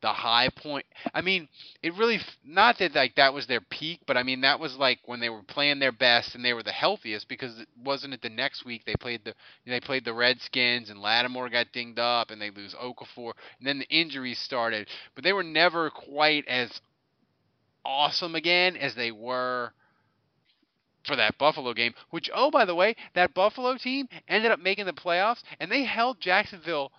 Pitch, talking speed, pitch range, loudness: 135 Hz, 200 wpm, 120-170 Hz, -26 LUFS